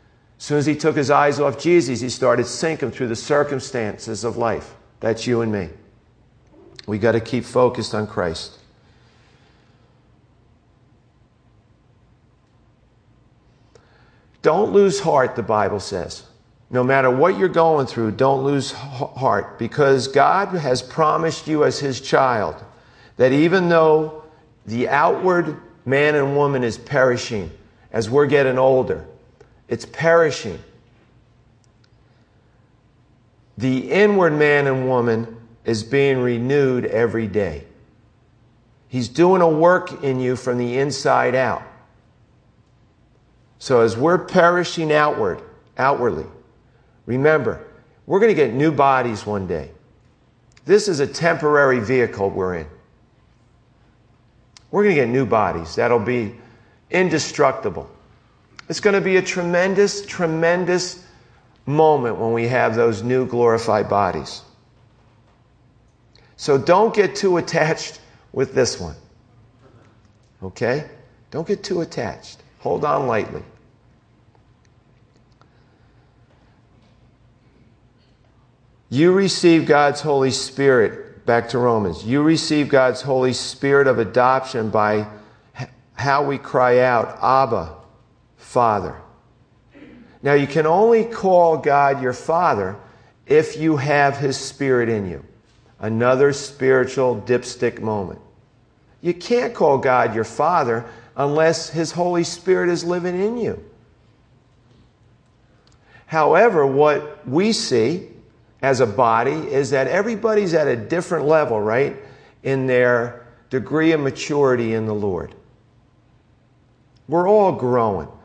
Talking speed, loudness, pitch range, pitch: 115 wpm, -19 LUFS, 115-150 Hz, 125 Hz